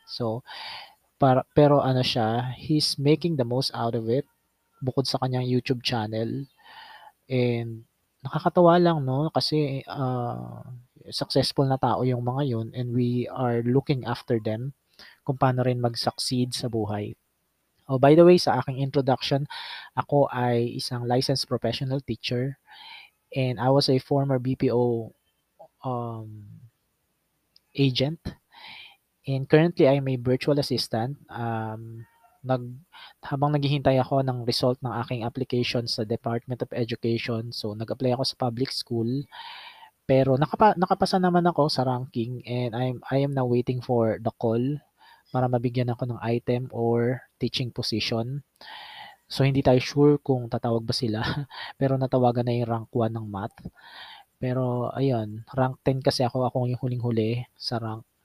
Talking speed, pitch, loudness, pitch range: 140 wpm, 125 Hz, -25 LUFS, 120-140 Hz